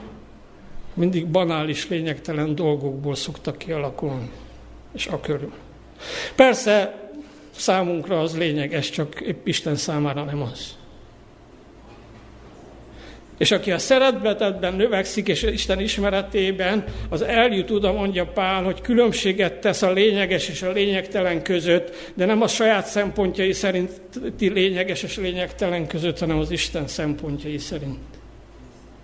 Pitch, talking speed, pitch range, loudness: 185 Hz, 120 wpm, 160-200 Hz, -22 LUFS